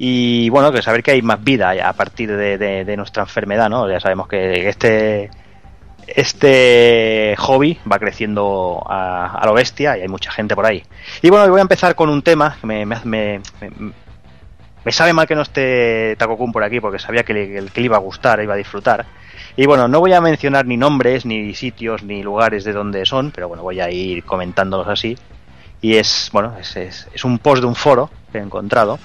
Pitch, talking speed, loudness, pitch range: 110 Hz, 215 wpm, -15 LUFS, 100-125 Hz